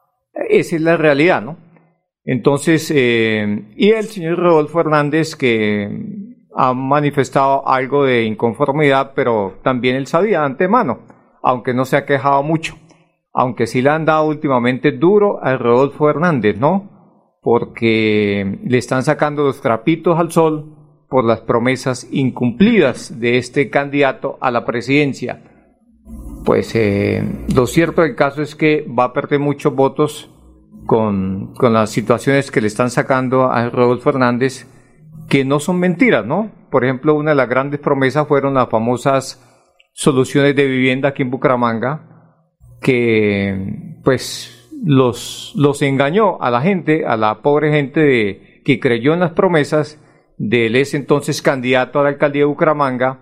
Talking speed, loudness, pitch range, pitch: 150 wpm, -15 LUFS, 125-155 Hz, 140 Hz